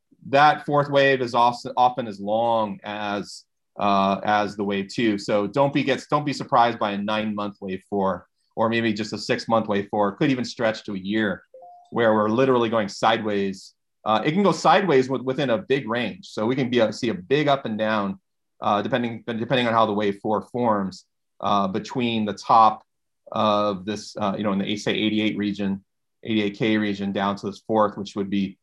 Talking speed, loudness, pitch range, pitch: 215 wpm, -23 LUFS, 100-120 Hz, 110 Hz